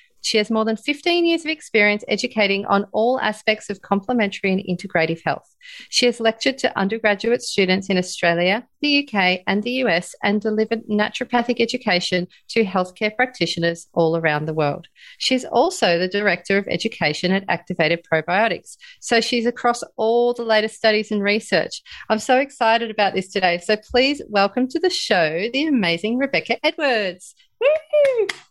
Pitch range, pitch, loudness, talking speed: 185-250 Hz, 215 Hz, -20 LUFS, 160 wpm